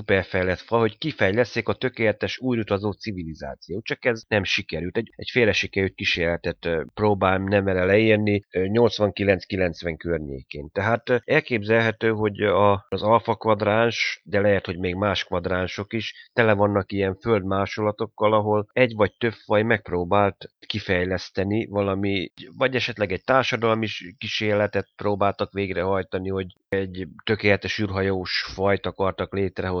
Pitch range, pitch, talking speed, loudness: 95-110 Hz, 100 Hz, 120 wpm, -23 LUFS